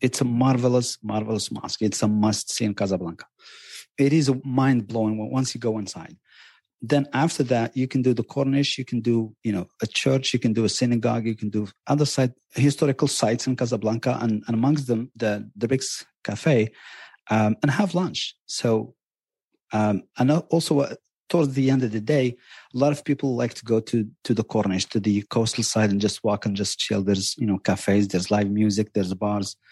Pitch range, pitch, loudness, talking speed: 105-130 Hz, 115 Hz, -23 LUFS, 205 wpm